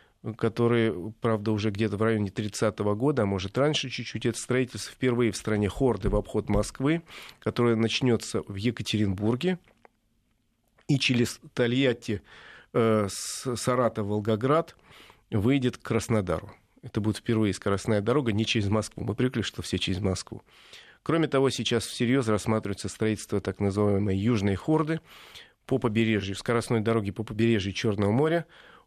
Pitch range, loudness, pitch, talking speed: 105-125 Hz, -27 LUFS, 115 Hz, 135 wpm